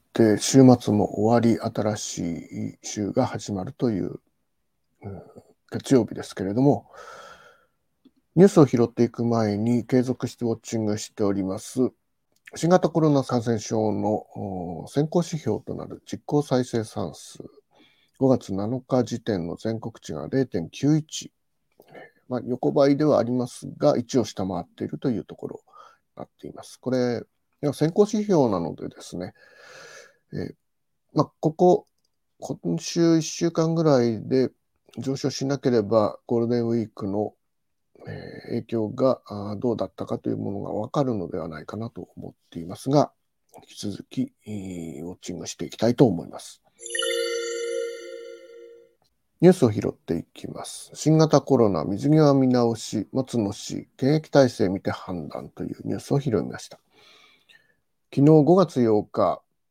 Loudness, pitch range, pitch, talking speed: -24 LUFS, 110-145 Hz, 125 Hz, 270 characters per minute